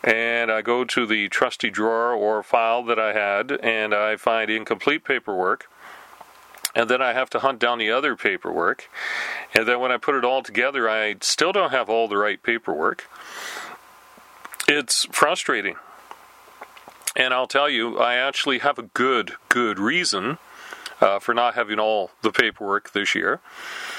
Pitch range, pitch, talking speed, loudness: 105-120 Hz, 115 Hz, 165 wpm, -21 LUFS